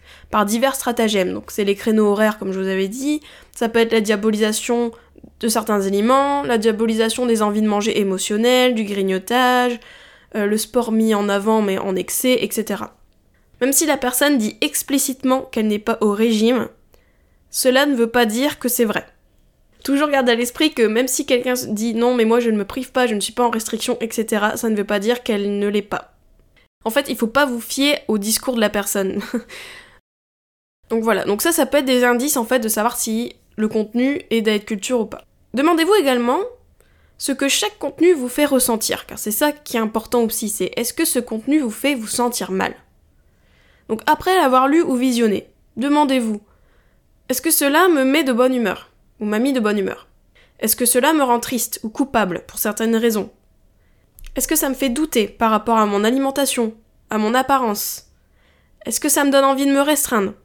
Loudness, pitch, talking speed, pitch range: -18 LUFS, 235 Hz, 205 wpm, 215-265 Hz